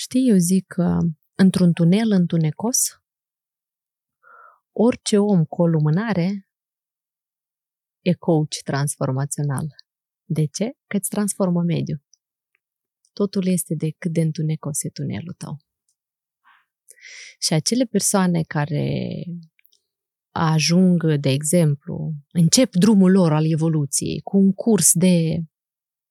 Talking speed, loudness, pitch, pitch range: 105 wpm, -20 LUFS, 175 Hz, 155-195 Hz